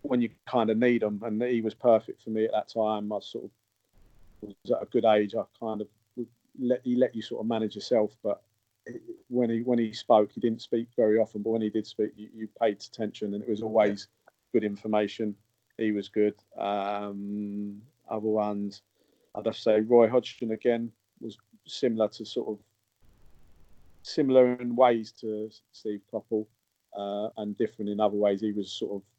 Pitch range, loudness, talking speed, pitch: 105-115 Hz, -28 LUFS, 195 wpm, 110 Hz